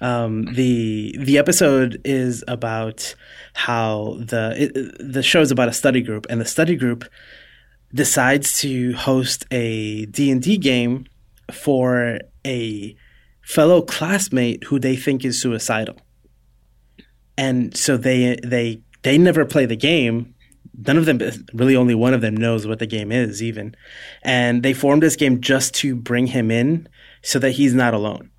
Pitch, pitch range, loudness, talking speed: 125 Hz, 115-135 Hz, -18 LUFS, 160 wpm